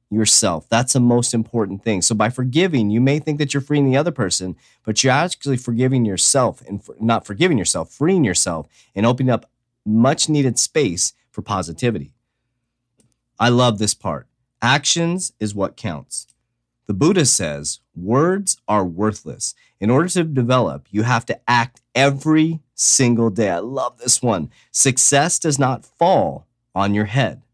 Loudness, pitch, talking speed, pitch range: -18 LUFS, 120 Hz, 160 wpm, 110-135 Hz